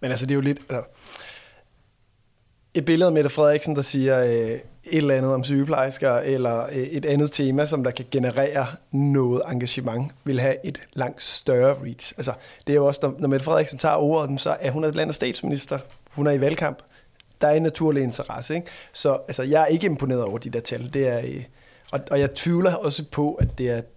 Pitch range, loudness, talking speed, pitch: 125-150 Hz, -23 LUFS, 220 wpm, 140 Hz